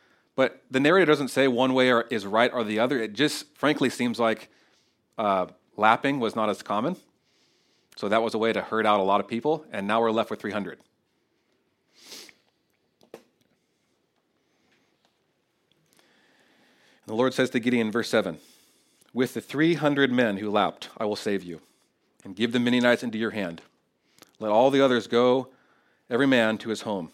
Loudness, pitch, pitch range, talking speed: -25 LUFS, 120 Hz, 110-130 Hz, 170 wpm